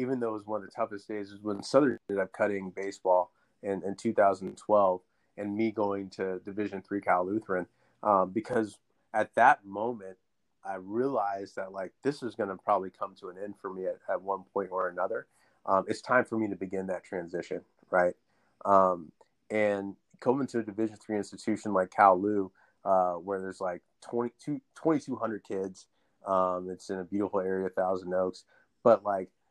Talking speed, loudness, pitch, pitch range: 180 wpm, -31 LUFS, 100 Hz, 95-110 Hz